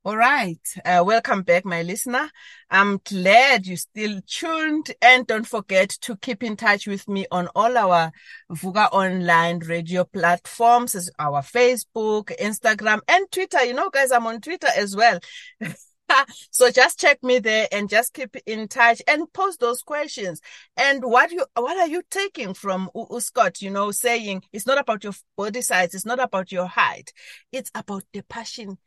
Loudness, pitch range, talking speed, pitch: -20 LUFS, 190-250 Hz, 170 wpm, 220 Hz